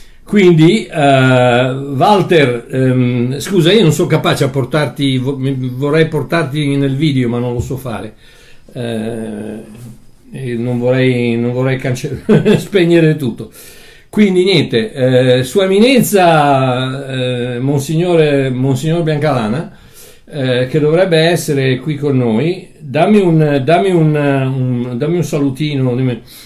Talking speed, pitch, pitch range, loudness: 120 wpm, 140 Hz, 125-160 Hz, -13 LUFS